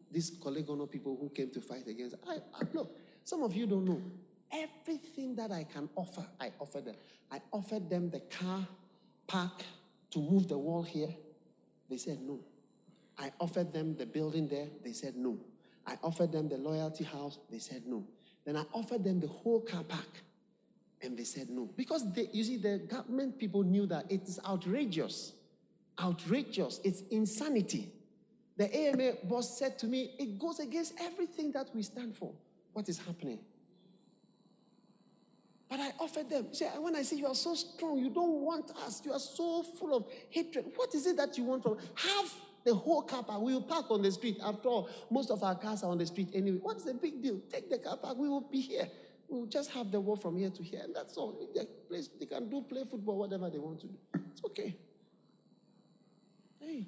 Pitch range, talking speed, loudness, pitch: 175-260 Hz, 200 wpm, -37 LUFS, 210 Hz